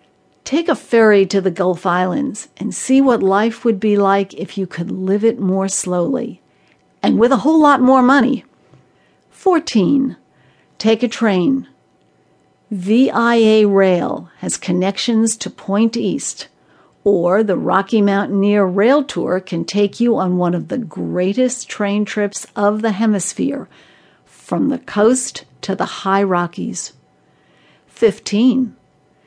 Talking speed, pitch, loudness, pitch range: 135 wpm, 210 Hz, -16 LUFS, 195-240 Hz